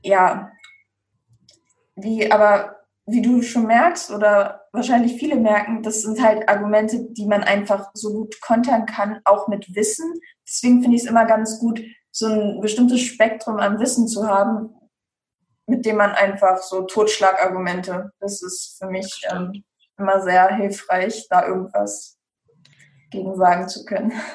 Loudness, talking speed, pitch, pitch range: -19 LUFS, 150 wpm, 210 Hz, 190-225 Hz